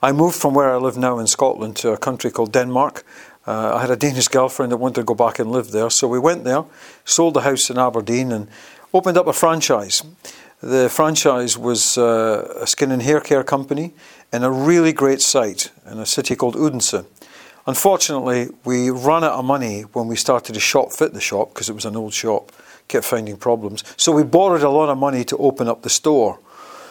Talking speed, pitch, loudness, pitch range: 215 wpm, 130 Hz, -18 LUFS, 120-150 Hz